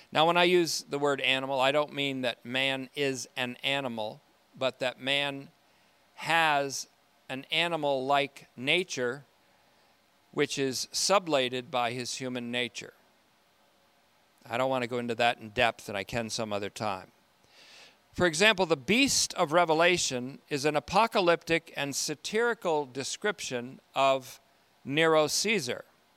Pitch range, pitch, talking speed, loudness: 125-160 Hz, 140 Hz, 140 wpm, -28 LUFS